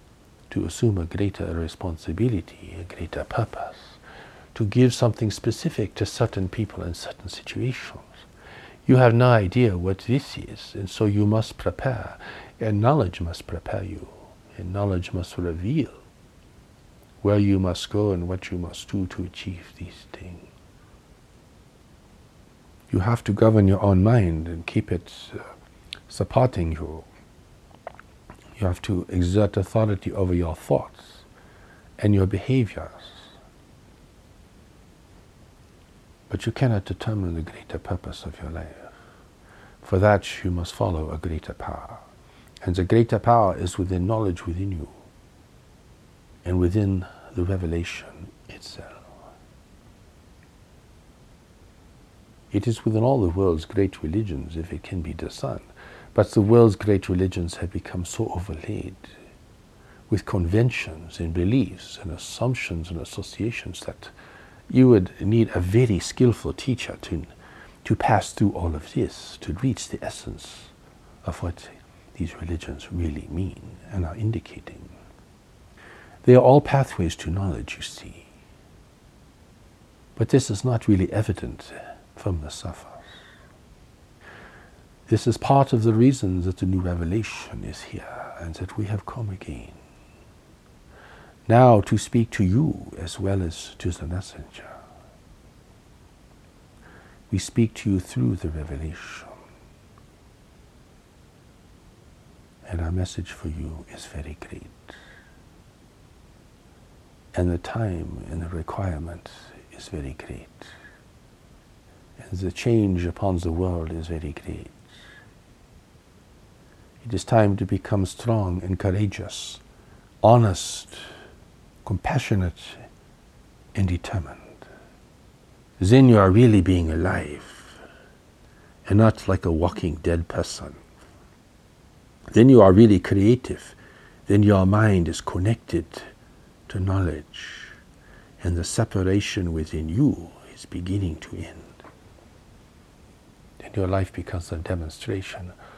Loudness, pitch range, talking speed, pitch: -23 LUFS, 85-110 Hz, 120 wpm, 95 Hz